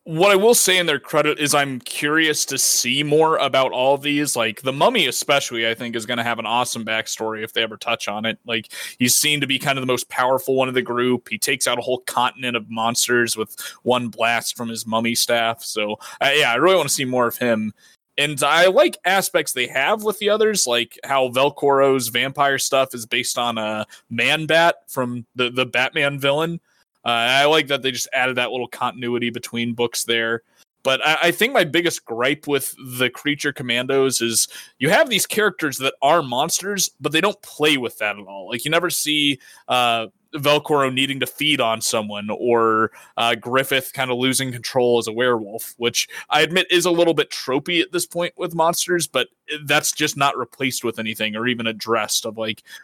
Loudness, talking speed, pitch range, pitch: -19 LUFS, 210 wpm, 115-150 Hz, 130 Hz